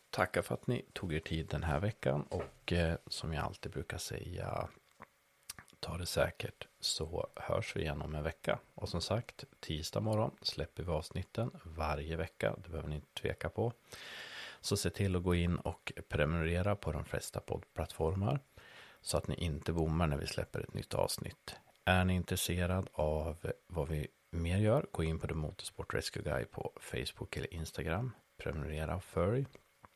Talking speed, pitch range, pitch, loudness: 170 wpm, 80-95 Hz, 85 Hz, -38 LUFS